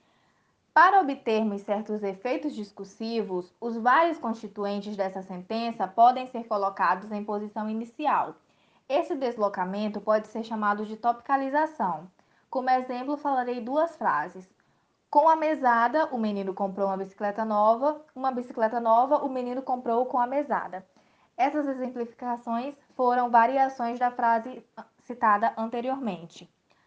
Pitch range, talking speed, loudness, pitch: 210-255 Hz, 120 wpm, -27 LUFS, 235 Hz